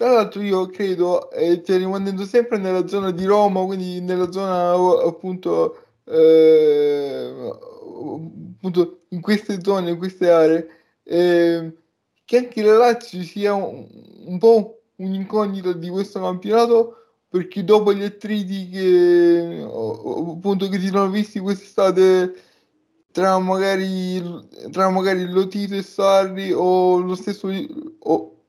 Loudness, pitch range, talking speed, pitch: -19 LUFS, 180-210 Hz, 120 wpm, 195 Hz